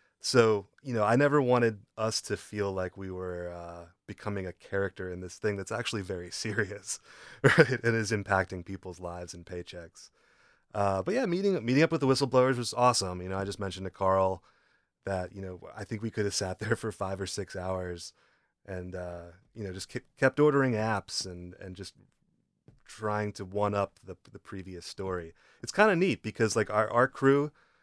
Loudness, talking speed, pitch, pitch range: -30 LUFS, 200 wpm, 100 Hz, 95-115 Hz